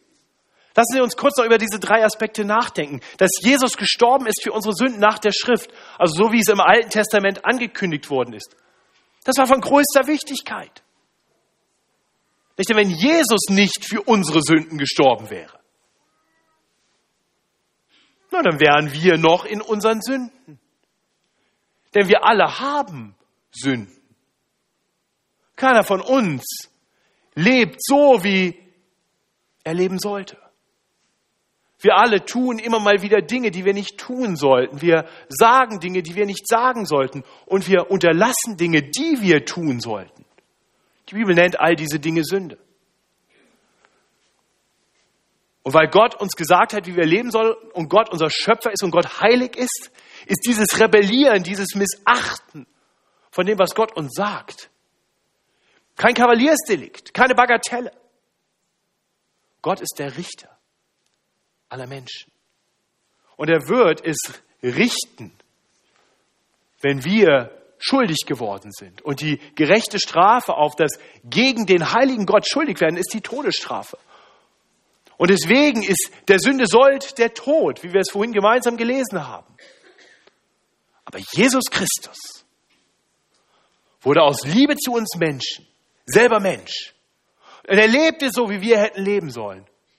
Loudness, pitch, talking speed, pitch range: -18 LUFS, 205 Hz, 135 wpm, 165-235 Hz